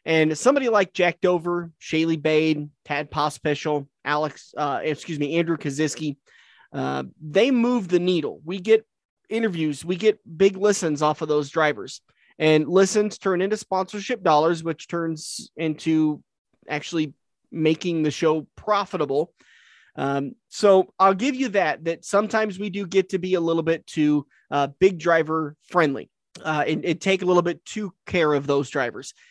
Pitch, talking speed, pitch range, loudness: 165 Hz, 160 wpm, 150-195 Hz, -23 LUFS